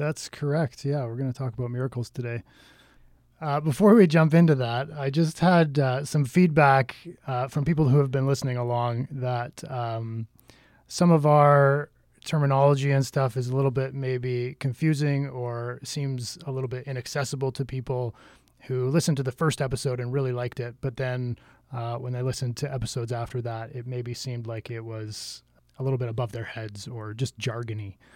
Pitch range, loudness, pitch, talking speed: 120-140 Hz, -26 LUFS, 130 Hz, 185 wpm